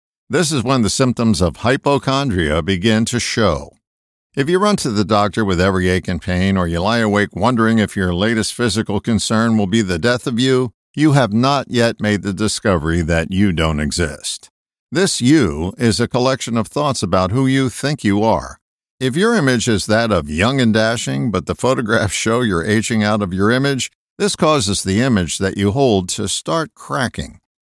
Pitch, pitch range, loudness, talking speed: 110 Hz, 95-125 Hz, -16 LUFS, 195 wpm